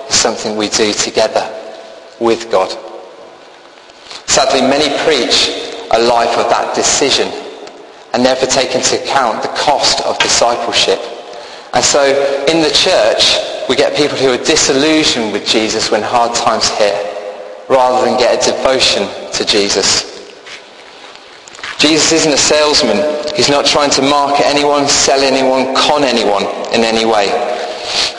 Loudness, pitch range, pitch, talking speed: -11 LUFS, 120-145 Hz, 135 Hz, 140 wpm